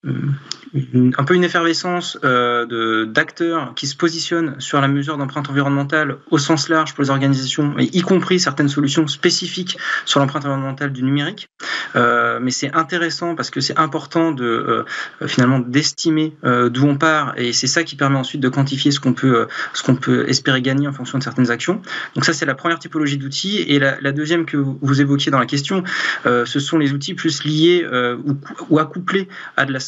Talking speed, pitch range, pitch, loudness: 205 wpm, 135-165 Hz, 145 Hz, -18 LUFS